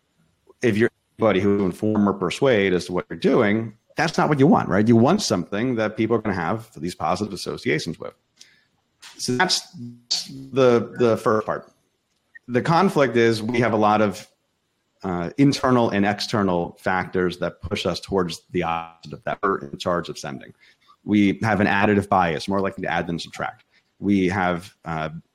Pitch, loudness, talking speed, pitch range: 100 Hz, -22 LUFS, 180 wpm, 90-115 Hz